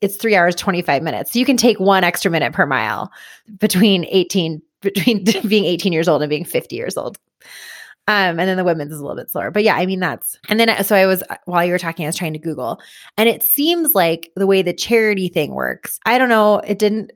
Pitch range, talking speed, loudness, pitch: 175-215 Hz, 245 wpm, -16 LUFS, 195 Hz